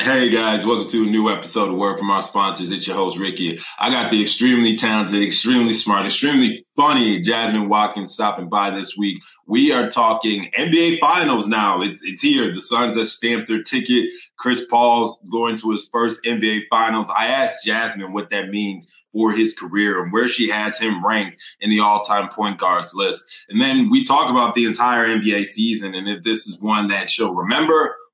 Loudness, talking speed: -18 LUFS, 200 wpm